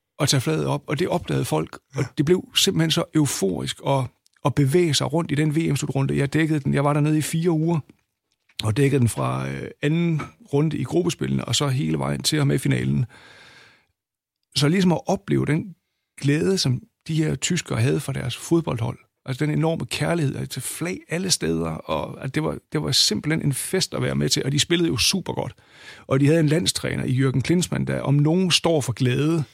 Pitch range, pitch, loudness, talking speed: 130-165 Hz, 145 Hz, -22 LUFS, 210 wpm